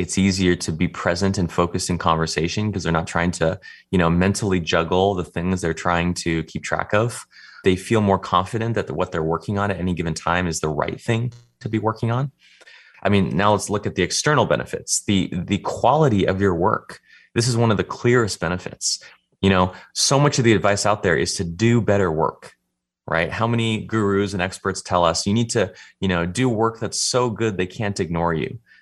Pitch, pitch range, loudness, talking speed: 95 Hz, 85-110 Hz, -21 LUFS, 220 wpm